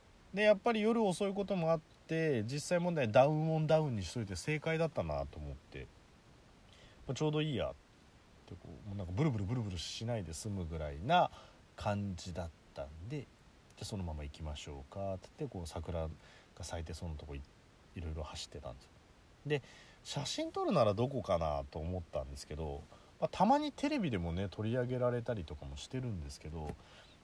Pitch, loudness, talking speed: 100 Hz, -37 LUFS, 385 characters per minute